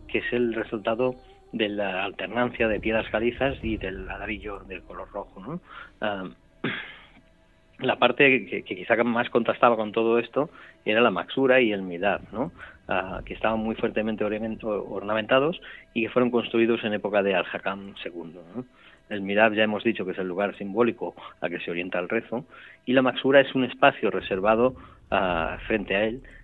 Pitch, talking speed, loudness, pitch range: 110 Hz, 175 wpm, -25 LUFS, 100-120 Hz